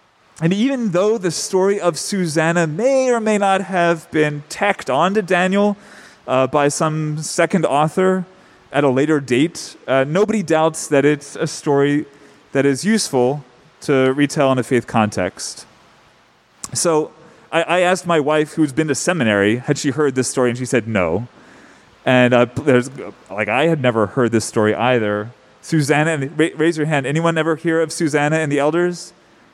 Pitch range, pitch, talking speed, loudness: 130-175 Hz, 150 Hz, 170 wpm, -17 LUFS